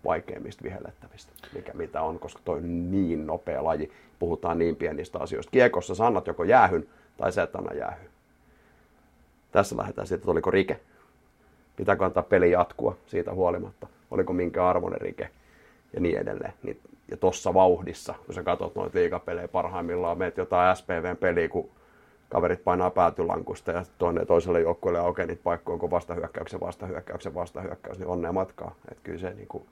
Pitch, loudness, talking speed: 90 Hz, -27 LUFS, 160 wpm